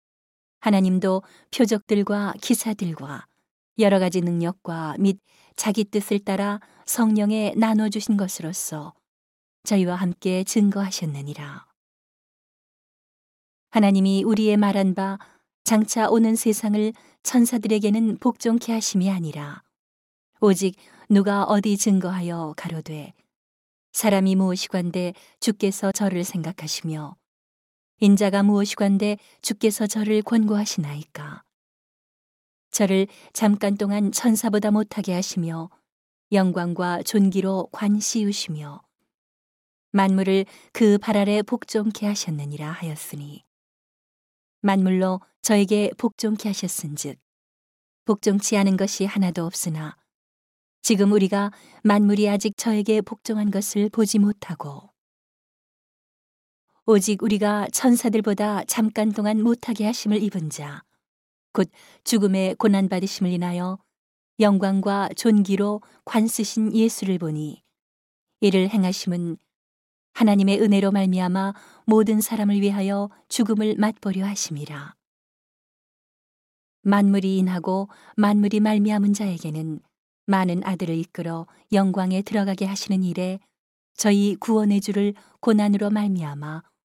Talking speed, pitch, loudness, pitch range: 250 characters per minute, 200 Hz, -22 LUFS, 185-215 Hz